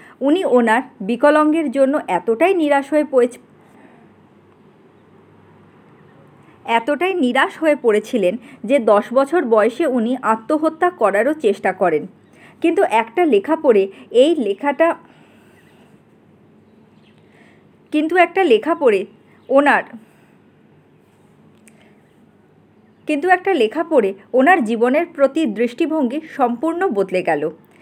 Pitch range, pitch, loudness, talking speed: 230-330 Hz, 280 Hz, -17 LUFS, 95 wpm